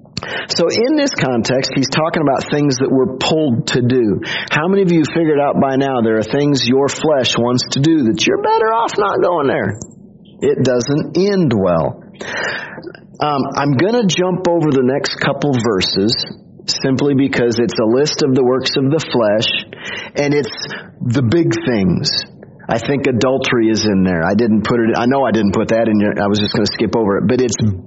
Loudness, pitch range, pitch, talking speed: -15 LUFS, 115-155 Hz, 135 Hz, 200 wpm